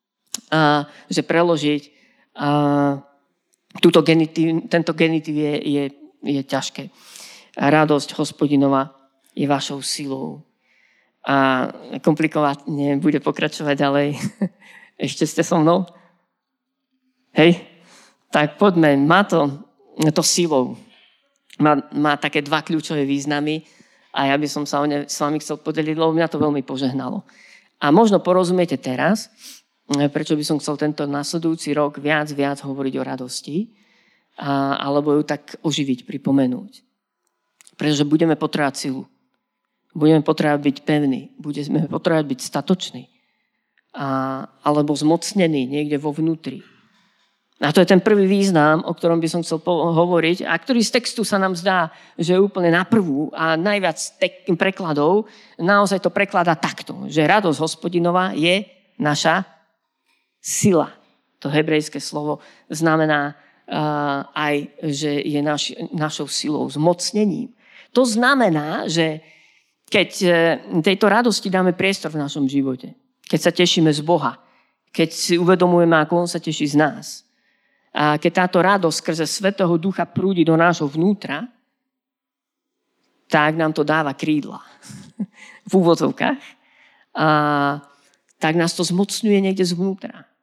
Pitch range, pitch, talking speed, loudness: 145-185 Hz, 160 Hz, 130 wpm, -19 LUFS